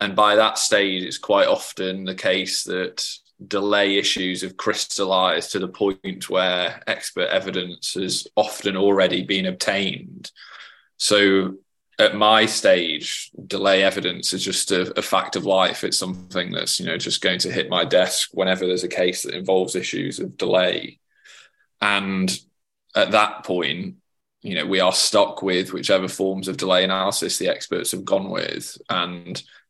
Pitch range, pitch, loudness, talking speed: 90-100 Hz, 95 Hz, -21 LUFS, 160 wpm